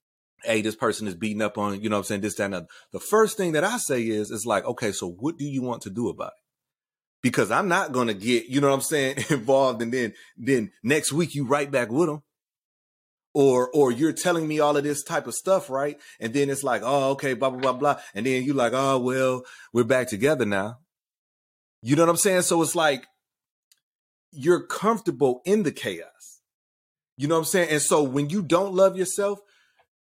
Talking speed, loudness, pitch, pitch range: 225 wpm, -24 LUFS, 135 Hz, 115-165 Hz